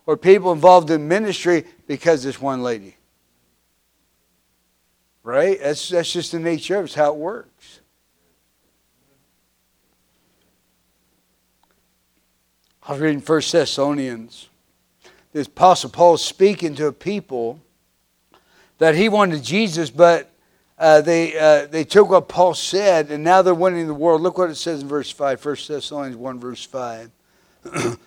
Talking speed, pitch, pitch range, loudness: 140 wpm, 150 Hz, 120-175 Hz, -18 LUFS